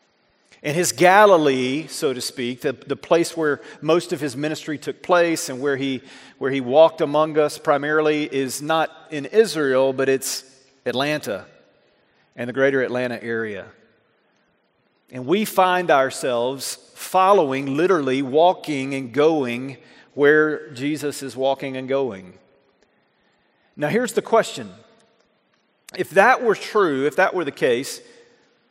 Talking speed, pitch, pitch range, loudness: 135 wpm, 145 Hz, 135-160 Hz, -20 LUFS